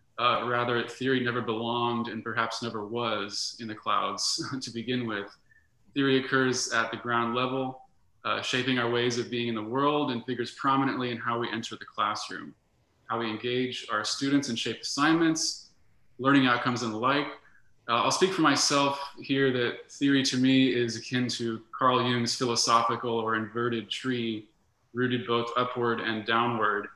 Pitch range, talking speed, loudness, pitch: 115-130 Hz, 170 wpm, -28 LUFS, 120 Hz